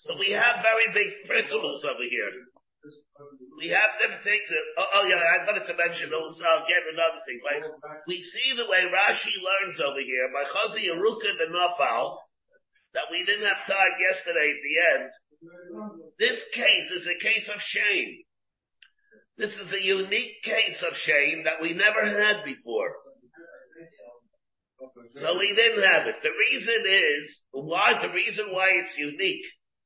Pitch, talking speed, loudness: 195 Hz, 165 wpm, -24 LUFS